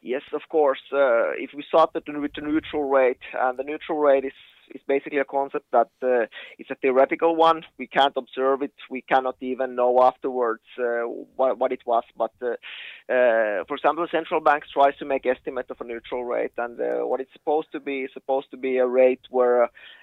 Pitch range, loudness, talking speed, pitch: 125-150 Hz, -23 LUFS, 210 wpm, 135 Hz